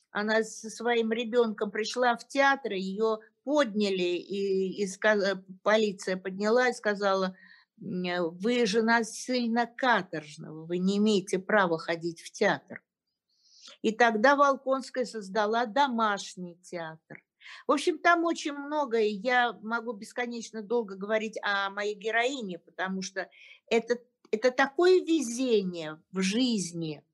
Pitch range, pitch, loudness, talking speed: 190-240 Hz, 220 Hz, -28 LUFS, 120 wpm